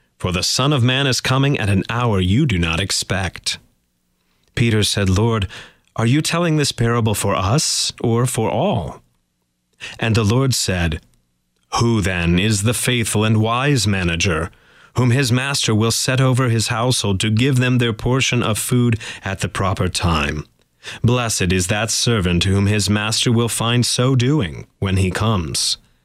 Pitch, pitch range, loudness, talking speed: 110 Hz, 95-125 Hz, -18 LUFS, 165 wpm